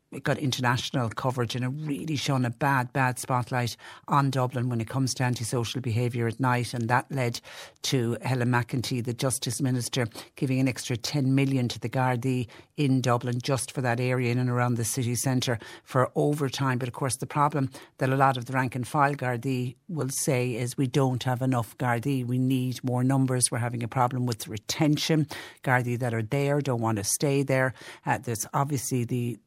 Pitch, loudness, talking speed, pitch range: 125 Hz, -27 LUFS, 200 wpm, 120-135 Hz